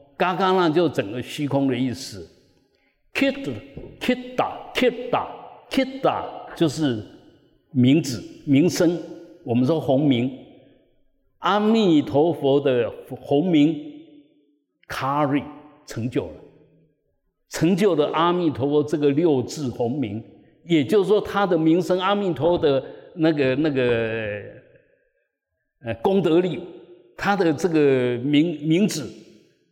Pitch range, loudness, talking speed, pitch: 140-195 Hz, -22 LUFS, 190 characters per minute, 160 Hz